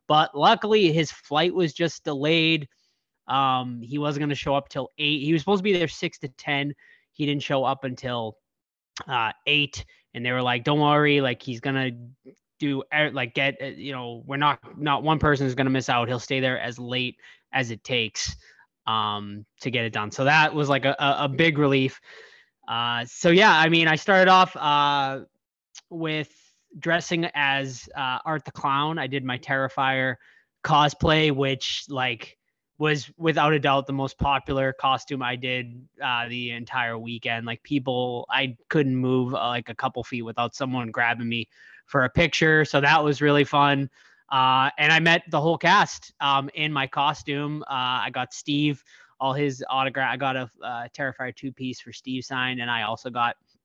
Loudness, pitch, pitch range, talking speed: -23 LUFS, 135 Hz, 125-150 Hz, 190 wpm